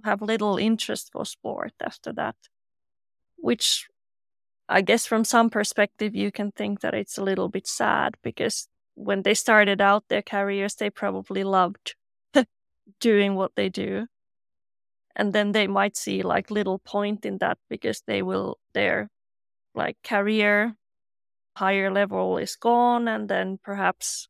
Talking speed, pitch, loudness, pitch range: 145 wpm, 200 Hz, -24 LUFS, 180-210 Hz